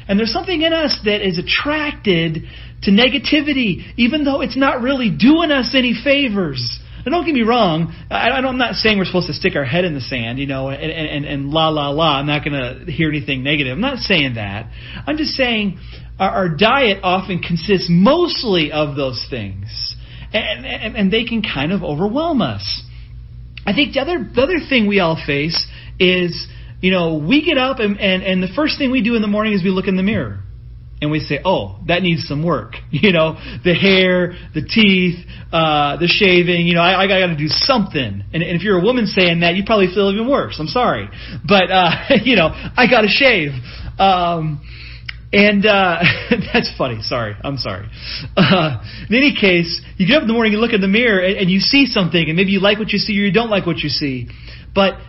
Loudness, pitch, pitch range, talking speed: -15 LUFS, 185 Hz, 150-220 Hz, 220 wpm